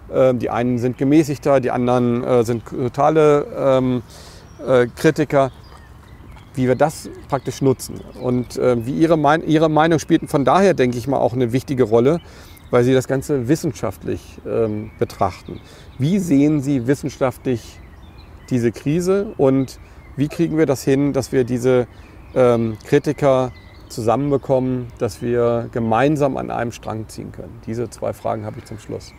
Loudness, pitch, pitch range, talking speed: -18 LUFS, 125 Hz, 115-140 Hz, 150 wpm